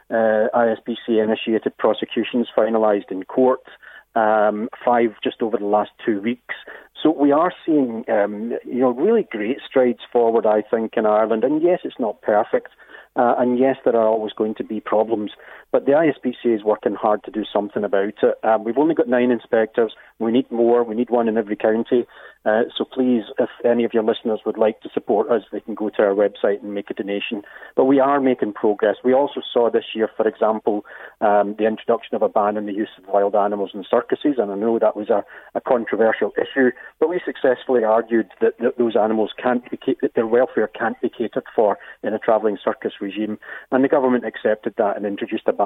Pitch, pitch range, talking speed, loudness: 115 Hz, 110-125 Hz, 210 wpm, -20 LUFS